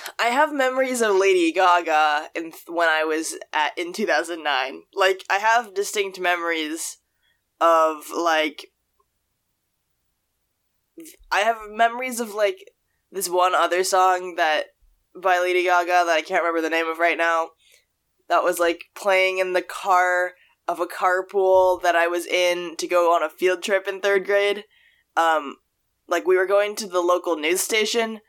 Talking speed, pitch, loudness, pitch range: 160 wpm, 180 Hz, -21 LUFS, 170-200 Hz